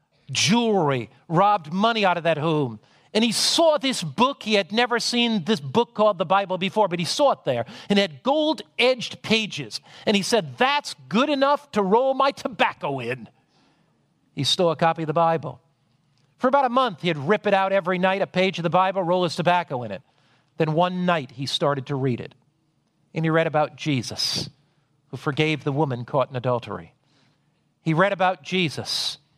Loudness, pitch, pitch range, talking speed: -22 LUFS, 175 Hz, 145-210 Hz, 195 wpm